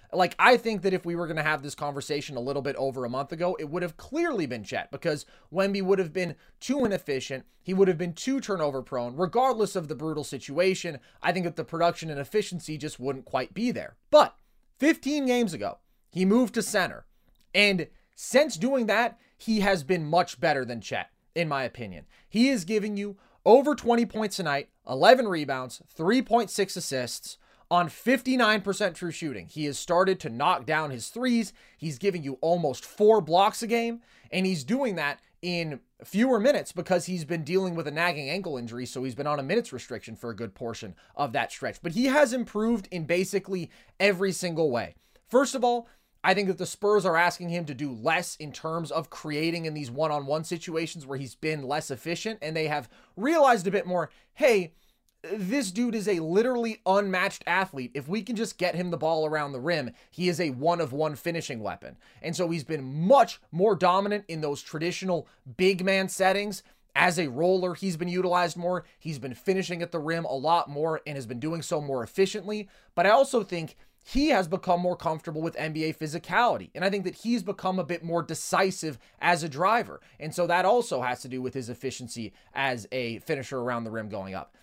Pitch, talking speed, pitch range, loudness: 175 Hz, 205 wpm, 150-200 Hz, -27 LUFS